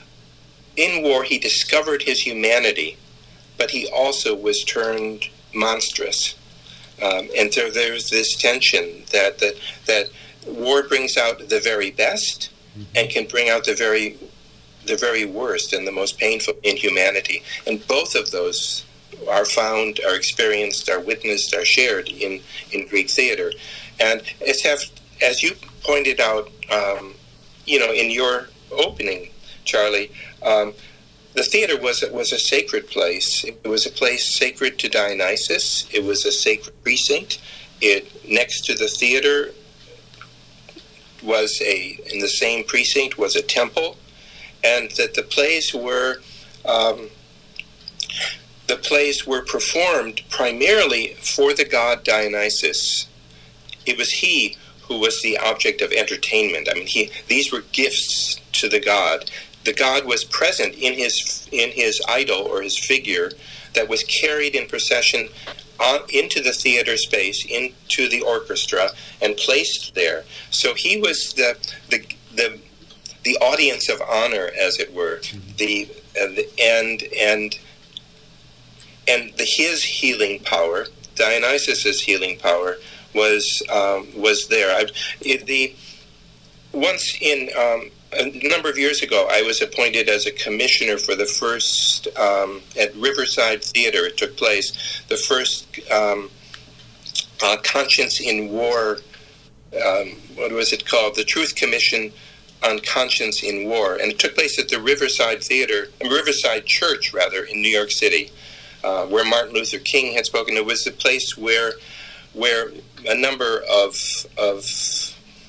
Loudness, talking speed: -19 LUFS, 140 wpm